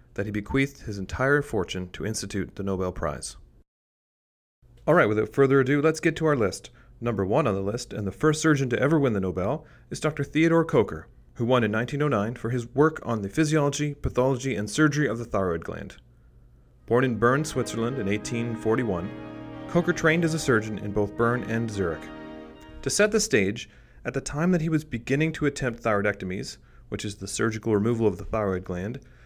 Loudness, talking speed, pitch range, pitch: -25 LUFS, 195 wpm, 100-145 Hz, 115 Hz